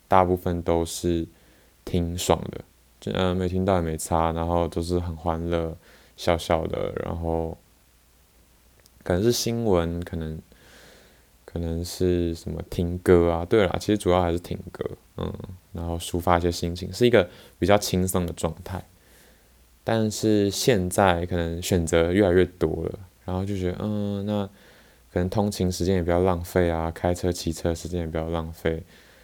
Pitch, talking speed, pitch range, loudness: 85 Hz, 240 characters per minute, 85-95 Hz, -25 LUFS